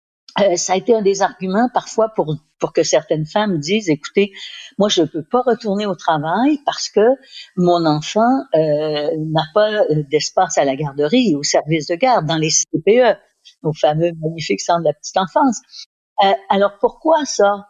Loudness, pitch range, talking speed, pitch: -17 LUFS, 155-220 Hz, 180 wpm, 185 Hz